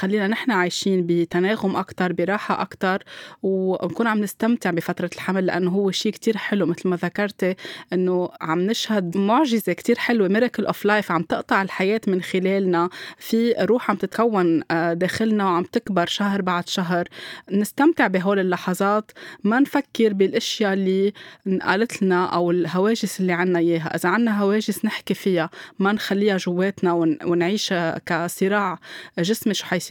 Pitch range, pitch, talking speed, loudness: 180-210 Hz, 190 Hz, 140 wpm, -22 LUFS